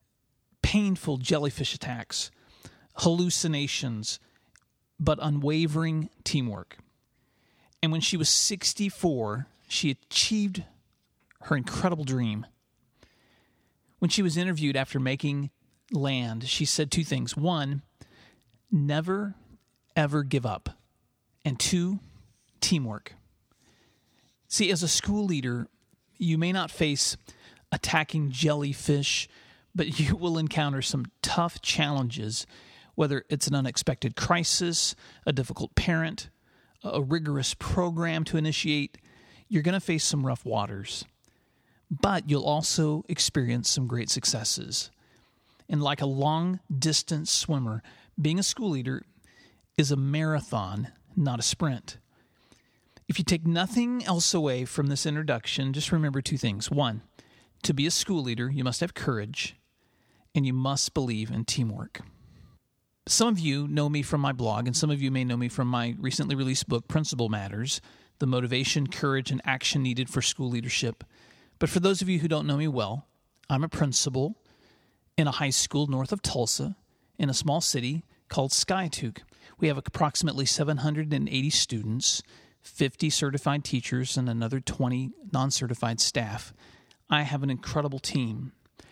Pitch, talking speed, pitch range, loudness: 145 Hz, 135 wpm, 125-160 Hz, -27 LUFS